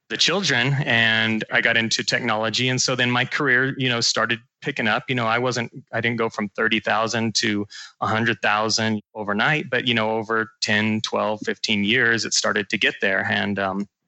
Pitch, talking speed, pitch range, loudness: 115 Hz, 195 wpm, 110-125 Hz, -21 LUFS